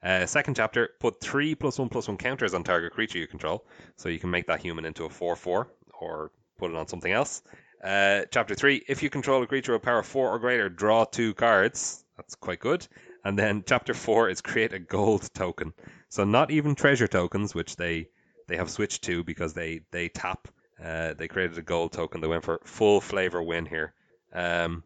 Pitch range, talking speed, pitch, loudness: 85-125 Hz, 210 wpm, 95 Hz, -27 LUFS